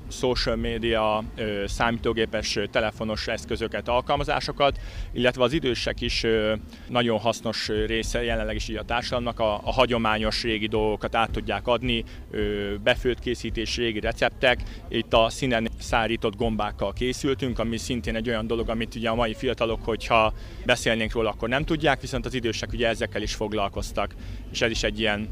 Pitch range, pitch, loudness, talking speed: 110-120 Hz, 115 Hz, -25 LUFS, 150 wpm